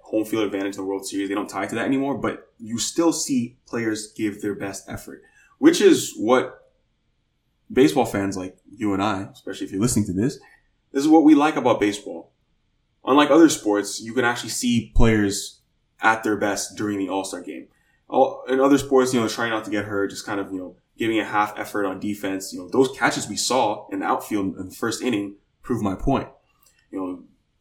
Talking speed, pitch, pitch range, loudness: 215 wpm, 105 Hz, 100-125 Hz, -22 LUFS